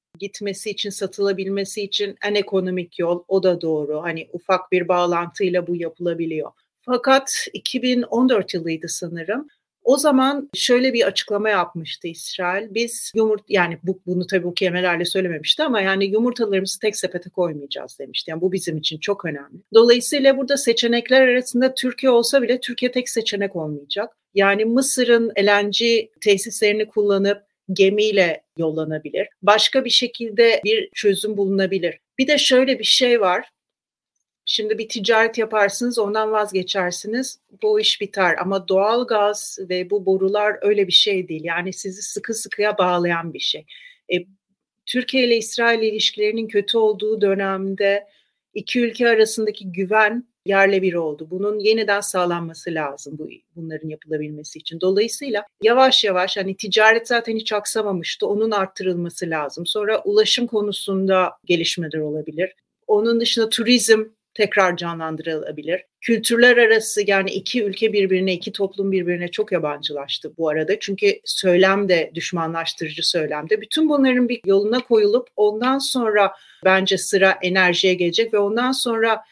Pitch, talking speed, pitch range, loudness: 200 Hz, 135 wpm, 180-225 Hz, -19 LUFS